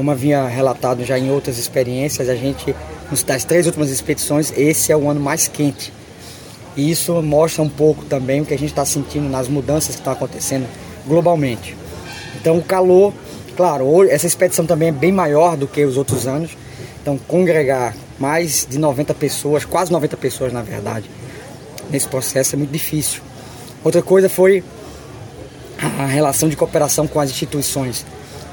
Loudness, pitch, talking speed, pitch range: -17 LUFS, 145 Hz, 165 wpm, 130-155 Hz